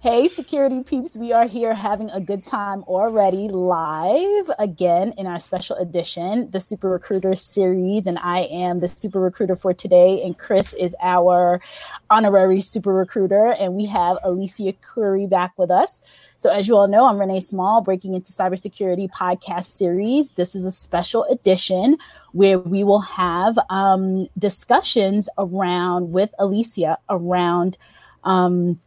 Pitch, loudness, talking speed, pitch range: 190 Hz, -19 LUFS, 150 wpm, 180-210 Hz